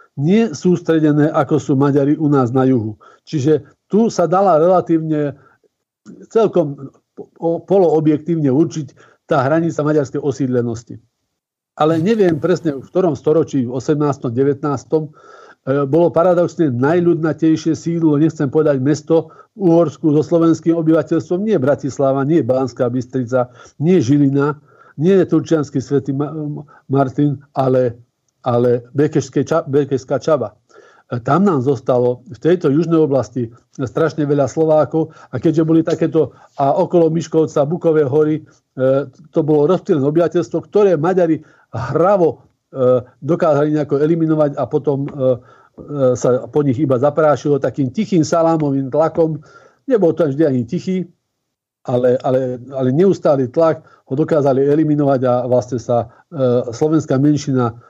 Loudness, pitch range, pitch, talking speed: -16 LUFS, 135-165 Hz, 150 Hz, 125 wpm